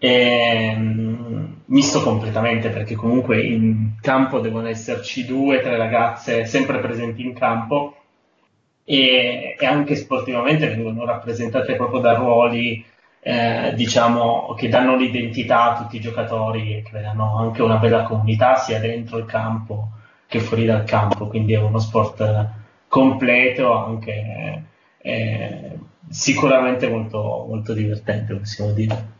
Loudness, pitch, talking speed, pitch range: -19 LUFS, 115 Hz, 130 wpm, 110-125 Hz